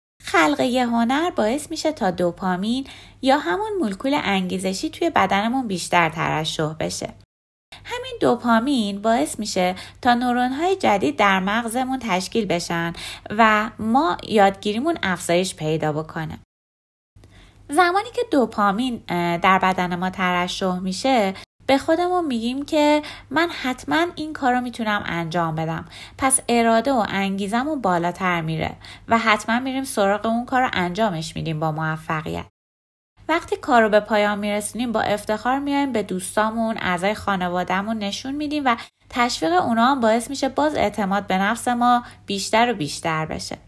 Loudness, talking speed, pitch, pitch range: -21 LUFS, 135 wpm, 215 Hz, 180-260 Hz